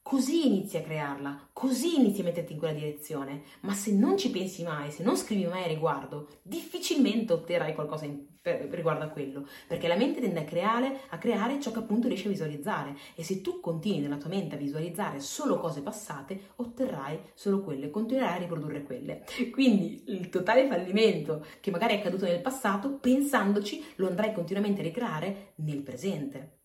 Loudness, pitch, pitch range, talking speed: -30 LUFS, 185 Hz, 155-230 Hz, 180 wpm